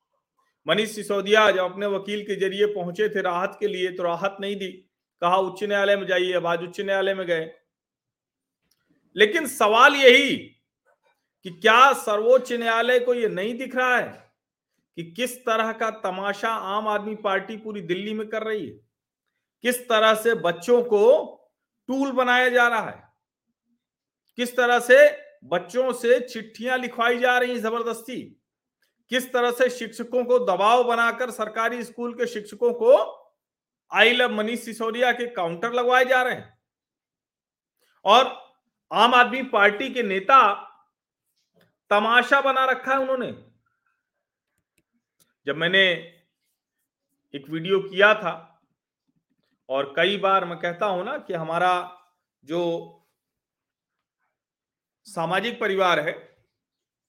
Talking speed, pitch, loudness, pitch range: 135 wpm, 225 Hz, -21 LUFS, 195-250 Hz